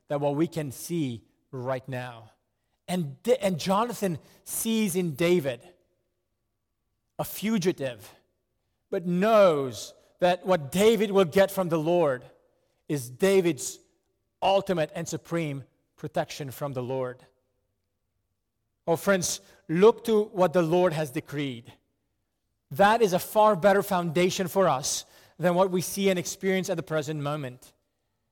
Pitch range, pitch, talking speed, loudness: 125-190 Hz, 160 Hz, 130 wpm, -26 LUFS